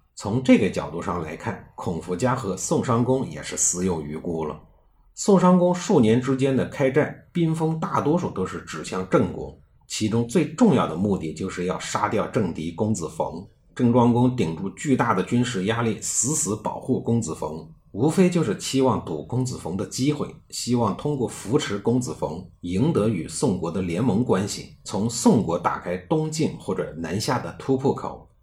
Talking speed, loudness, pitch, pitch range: 270 characters per minute, -23 LUFS, 120 Hz, 95-150 Hz